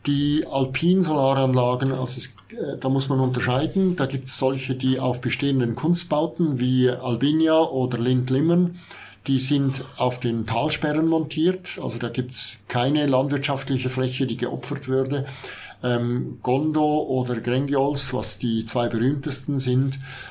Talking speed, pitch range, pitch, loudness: 135 wpm, 125-145 Hz, 130 Hz, -23 LUFS